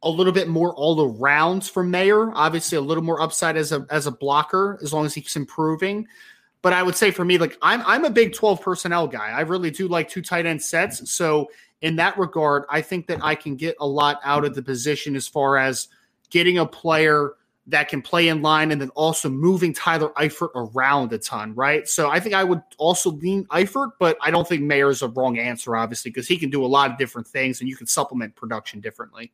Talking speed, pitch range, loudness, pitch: 235 wpm, 140-180 Hz, -21 LUFS, 155 Hz